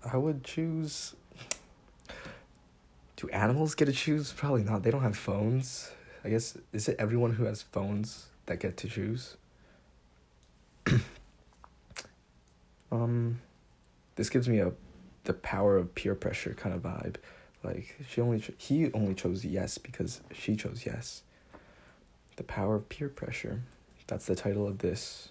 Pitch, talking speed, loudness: 105 Hz, 145 wpm, -33 LUFS